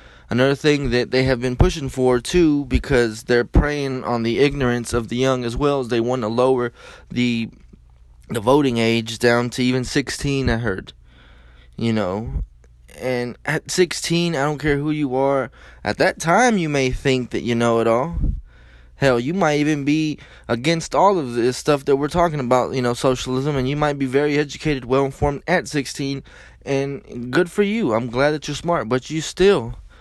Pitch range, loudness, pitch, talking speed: 120-145 Hz, -20 LUFS, 130 Hz, 190 wpm